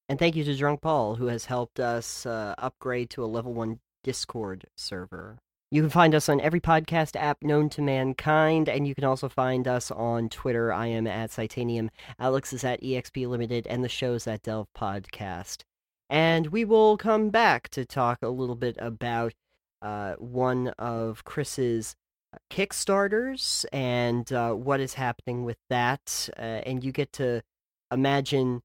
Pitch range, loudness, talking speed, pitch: 115-145 Hz, -27 LUFS, 170 wpm, 125 Hz